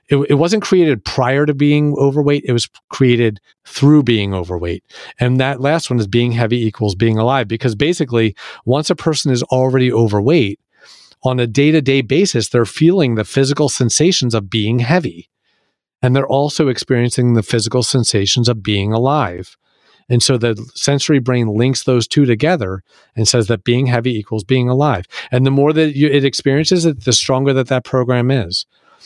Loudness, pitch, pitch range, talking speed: -15 LUFS, 125 Hz, 115-140 Hz, 175 wpm